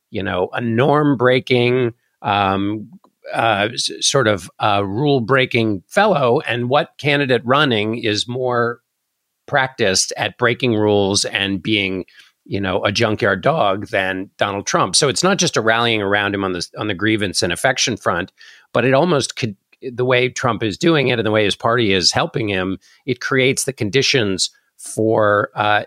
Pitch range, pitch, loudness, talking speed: 100-130 Hz, 115 Hz, -17 LUFS, 165 wpm